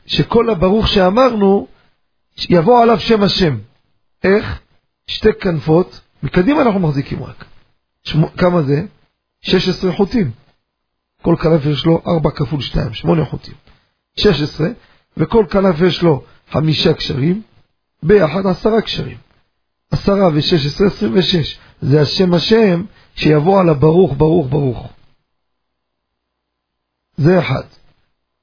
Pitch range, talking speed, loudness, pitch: 140-195 Hz, 110 wpm, -14 LUFS, 165 Hz